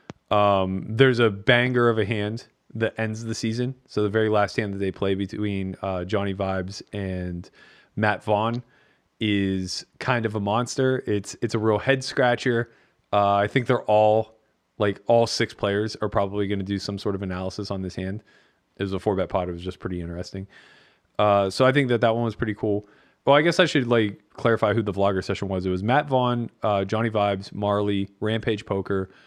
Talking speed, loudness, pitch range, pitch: 205 wpm, -24 LUFS, 100-115 Hz, 105 Hz